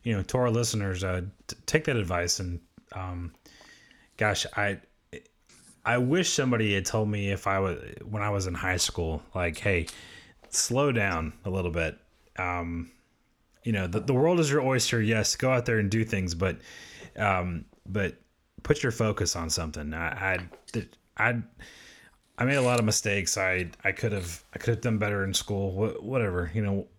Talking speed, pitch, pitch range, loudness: 185 wpm, 100 Hz, 90-115 Hz, -28 LUFS